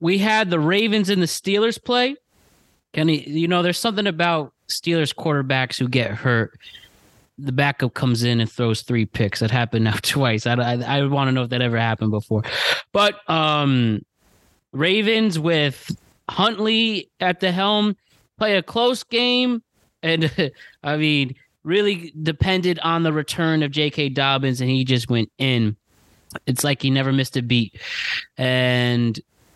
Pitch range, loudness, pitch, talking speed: 125-180 Hz, -20 LUFS, 145 Hz, 160 wpm